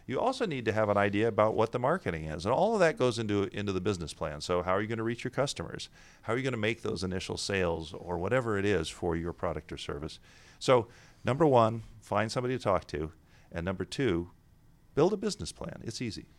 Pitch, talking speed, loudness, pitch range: 105 Hz, 240 wpm, -31 LUFS, 90-120 Hz